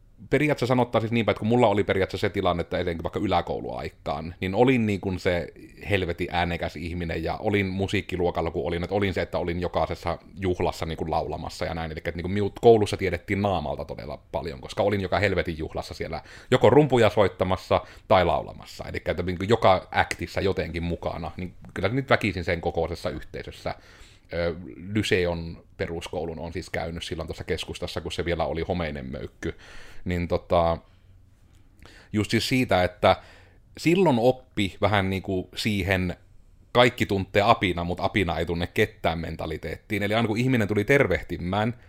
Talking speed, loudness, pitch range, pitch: 170 wpm, -25 LUFS, 85-105 Hz, 95 Hz